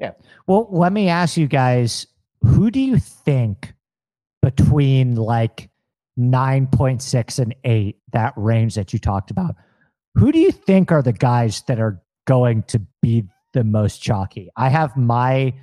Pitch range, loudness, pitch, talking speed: 115-140 Hz, -18 LUFS, 125 Hz, 155 wpm